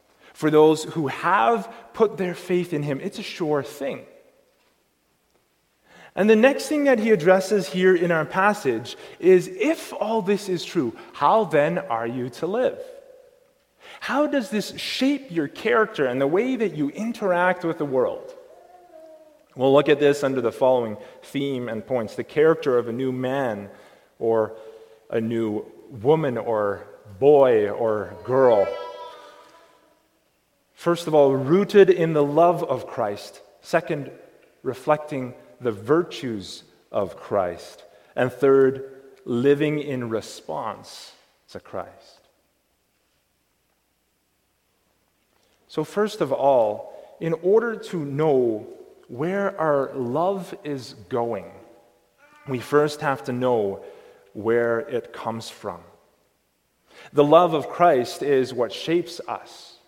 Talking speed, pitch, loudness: 125 wpm, 155 Hz, -22 LUFS